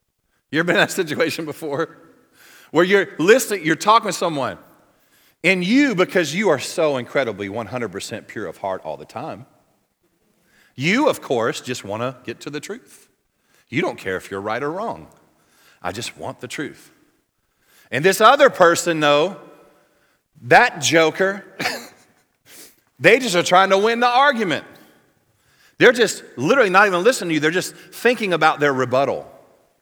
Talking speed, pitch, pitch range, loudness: 160 wpm, 175 Hz, 145-210 Hz, -18 LUFS